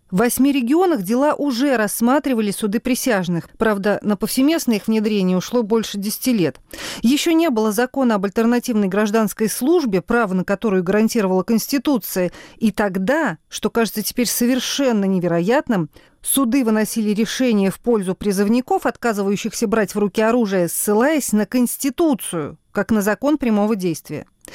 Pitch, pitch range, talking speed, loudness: 225 Hz, 205-250 Hz, 135 wpm, -19 LUFS